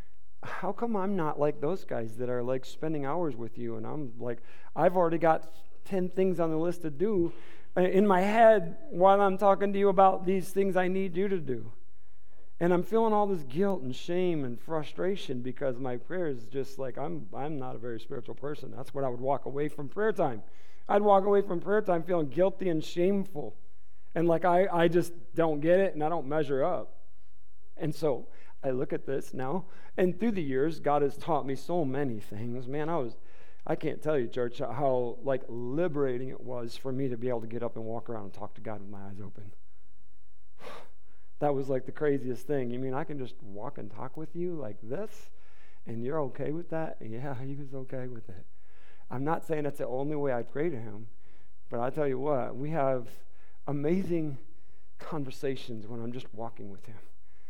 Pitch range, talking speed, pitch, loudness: 120-170 Hz, 210 wpm, 140 Hz, -31 LUFS